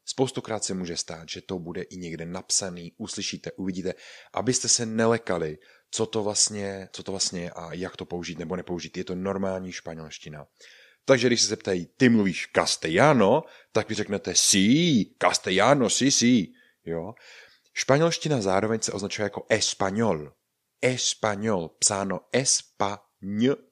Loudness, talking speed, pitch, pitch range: -25 LUFS, 145 wpm, 95 Hz, 90-115 Hz